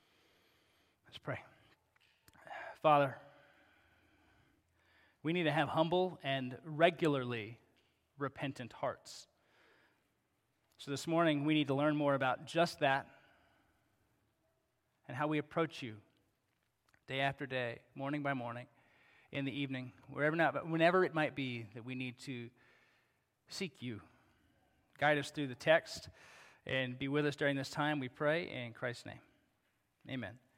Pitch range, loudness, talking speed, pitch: 125-150 Hz, -36 LUFS, 130 wpm, 140 Hz